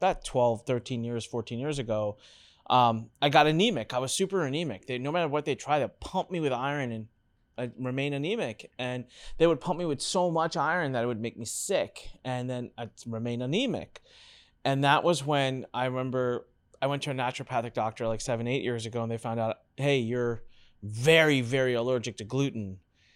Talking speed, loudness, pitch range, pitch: 200 wpm, -29 LUFS, 115-145 Hz, 125 Hz